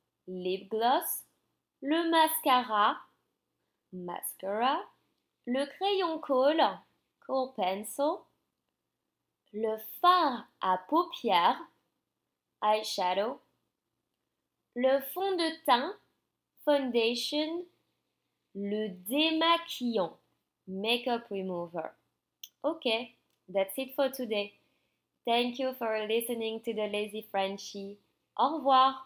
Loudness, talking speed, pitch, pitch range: -30 LUFS, 80 wpm, 240 Hz, 210-290 Hz